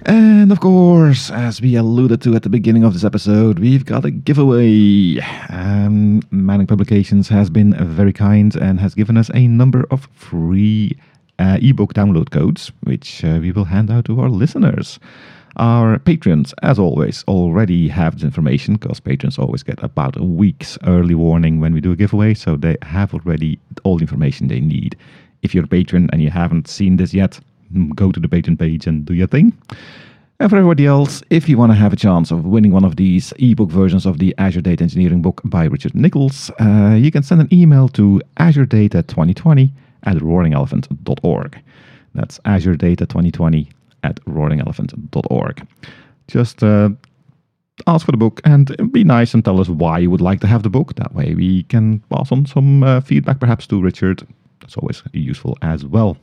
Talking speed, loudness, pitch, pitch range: 190 wpm, -14 LUFS, 105 Hz, 90-130 Hz